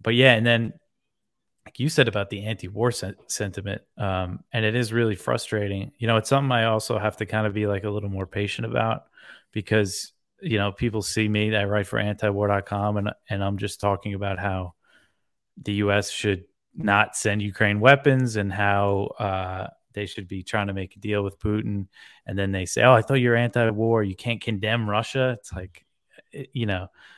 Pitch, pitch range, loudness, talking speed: 105 Hz, 100-115 Hz, -24 LUFS, 195 wpm